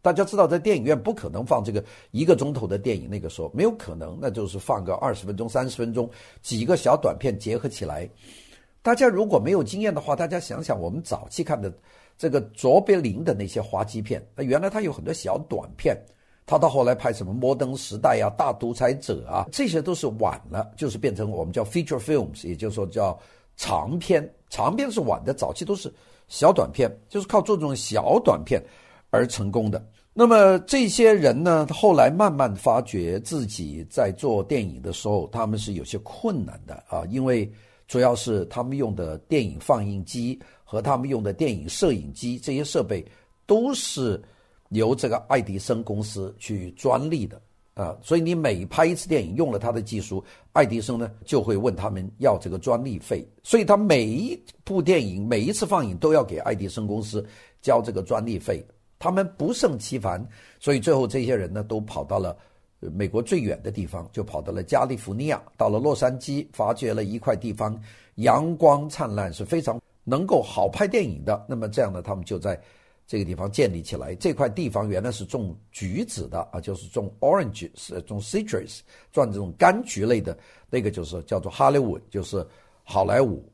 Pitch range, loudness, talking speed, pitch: 105-155 Hz, -24 LUFS, 305 characters per minute, 120 Hz